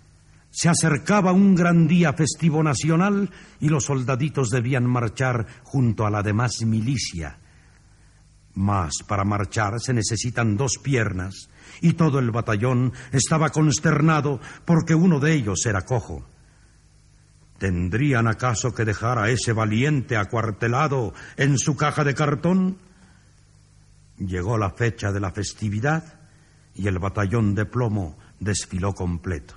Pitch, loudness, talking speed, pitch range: 120 Hz, -22 LUFS, 125 wpm, 100-150 Hz